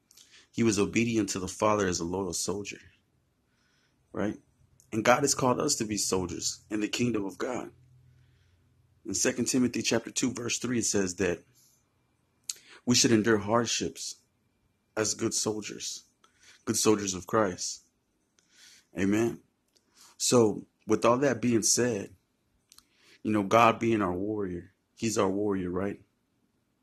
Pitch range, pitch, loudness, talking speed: 100-120 Hz, 110 Hz, -28 LUFS, 140 wpm